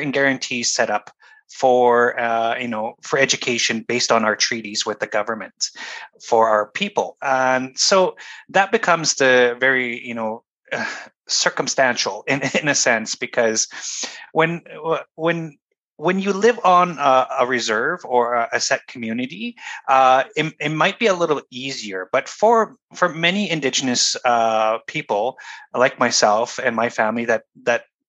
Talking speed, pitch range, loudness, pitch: 145 wpm, 120-170 Hz, -19 LUFS, 130 Hz